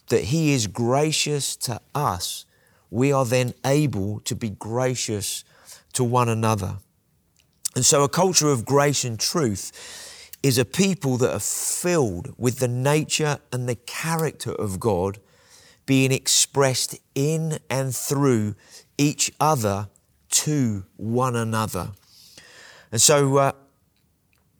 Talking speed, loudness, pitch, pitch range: 125 wpm, -22 LUFS, 130 Hz, 110-145 Hz